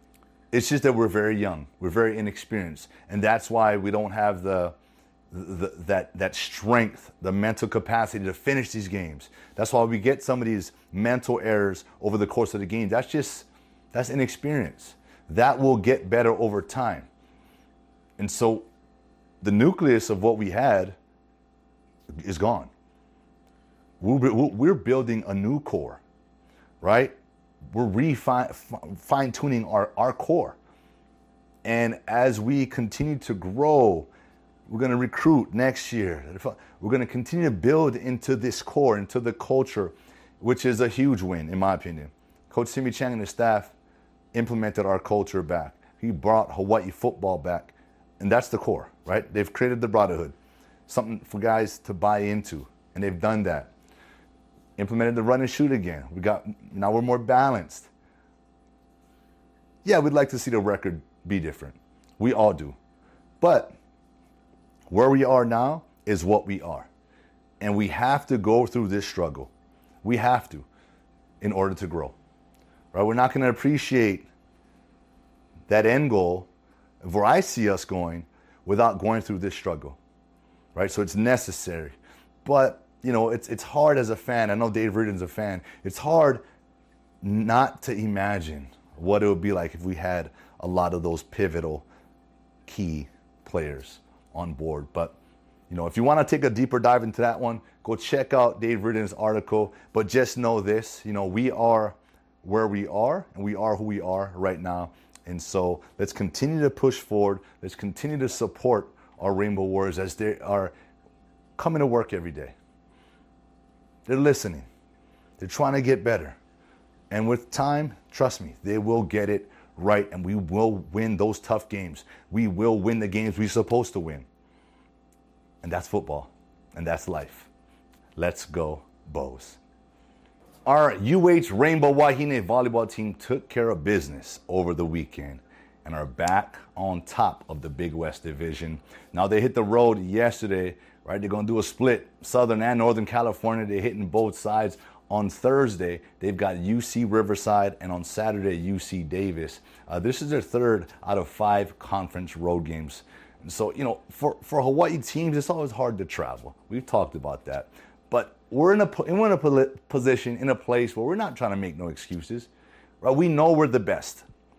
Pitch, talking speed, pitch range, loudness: 105 Hz, 170 wpm, 90-120 Hz, -25 LUFS